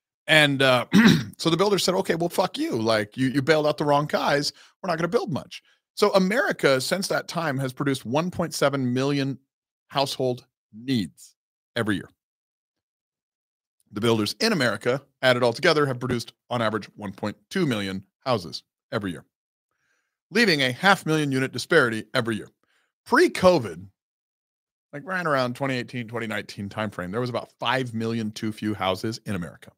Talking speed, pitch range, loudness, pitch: 160 wpm, 115-155 Hz, -24 LUFS, 130 Hz